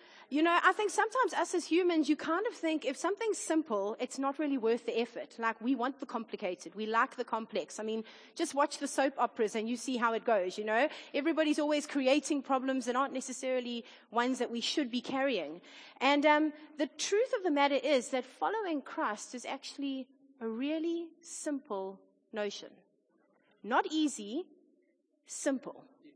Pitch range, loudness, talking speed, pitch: 240-315 Hz, -33 LUFS, 180 wpm, 275 Hz